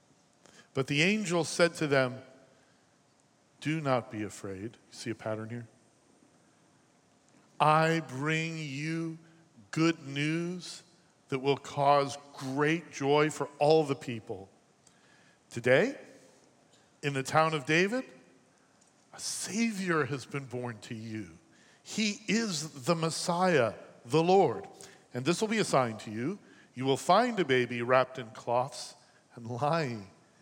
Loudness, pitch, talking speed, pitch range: -30 LUFS, 145 Hz, 125 wpm, 125-165 Hz